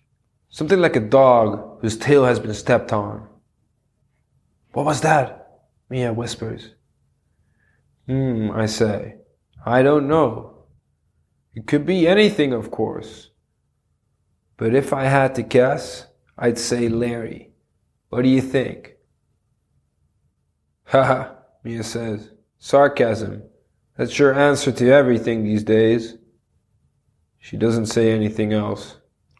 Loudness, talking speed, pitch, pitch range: -19 LUFS, 115 wpm, 120 Hz, 110-135 Hz